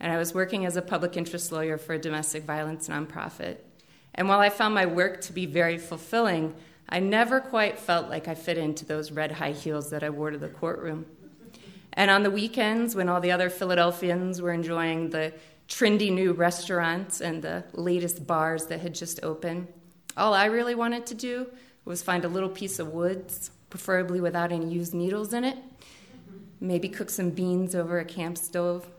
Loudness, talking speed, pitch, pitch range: -27 LUFS, 195 wpm, 175 Hz, 165-190 Hz